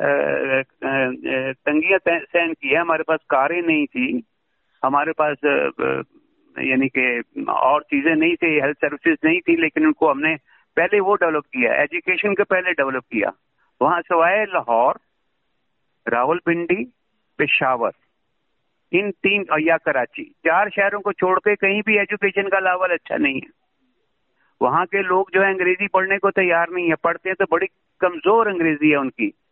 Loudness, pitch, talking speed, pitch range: -19 LUFS, 185 Hz, 150 wpm, 160-205 Hz